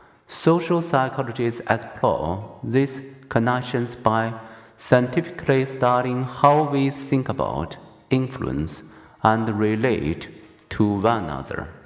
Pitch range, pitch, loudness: 115-135 Hz, 125 Hz, -22 LUFS